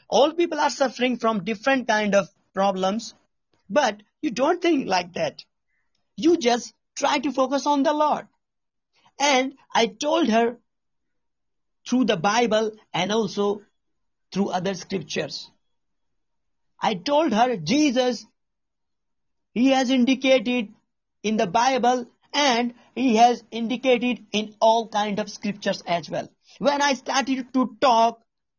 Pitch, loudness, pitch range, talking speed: 240 Hz, -23 LUFS, 215-270 Hz, 130 wpm